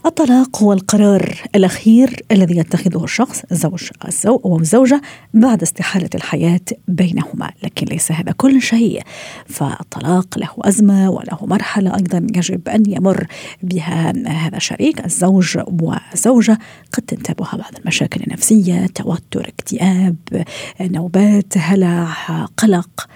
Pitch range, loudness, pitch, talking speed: 175-220 Hz, -15 LUFS, 190 Hz, 110 wpm